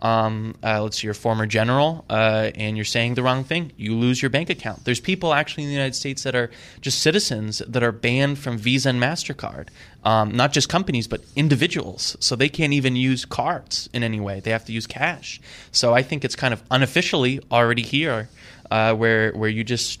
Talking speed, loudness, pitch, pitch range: 215 wpm, -21 LUFS, 120 Hz, 110-135 Hz